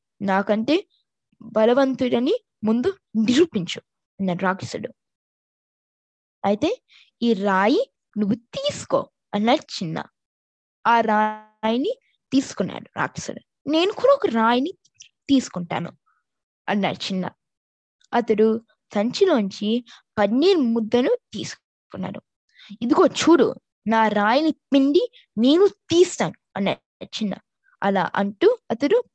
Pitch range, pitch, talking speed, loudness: 215-315 Hz, 235 Hz, 85 wpm, -22 LUFS